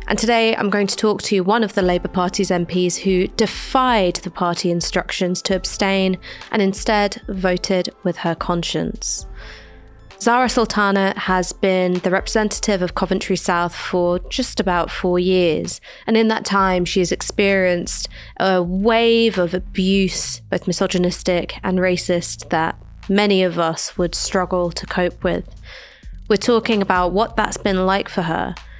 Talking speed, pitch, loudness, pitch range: 150 wpm, 185 Hz, -19 LUFS, 180-205 Hz